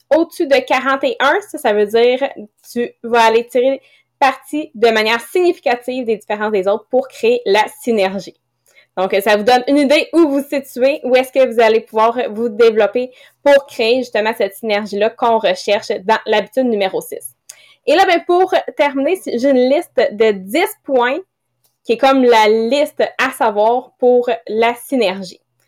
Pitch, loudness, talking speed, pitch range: 245 Hz, -15 LUFS, 175 wpm, 220-280 Hz